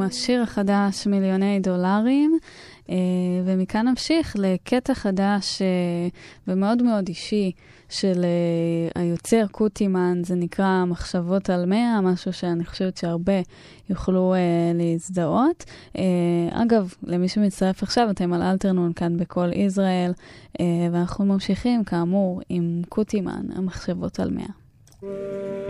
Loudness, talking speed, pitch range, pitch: -23 LUFS, 100 wpm, 175-205 Hz, 190 Hz